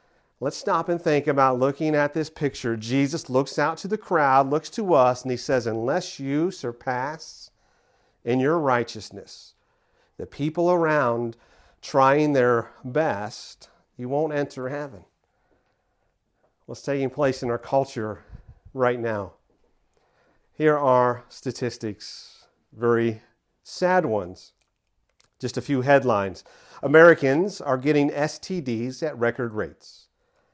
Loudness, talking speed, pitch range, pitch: -23 LUFS, 125 wpm, 120-150 Hz, 130 Hz